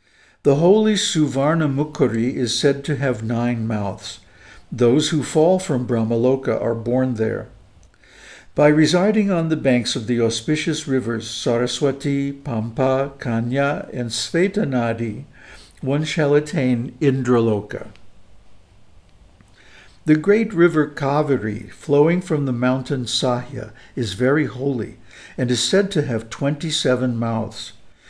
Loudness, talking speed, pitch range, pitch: -20 LUFS, 115 wpm, 115-150 Hz, 130 Hz